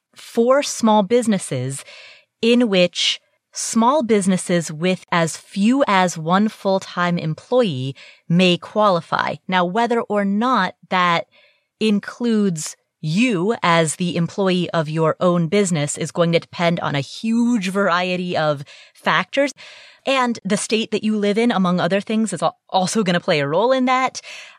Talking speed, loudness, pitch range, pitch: 145 wpm, -19 LUFS, 170-230 Hz, 195 Hz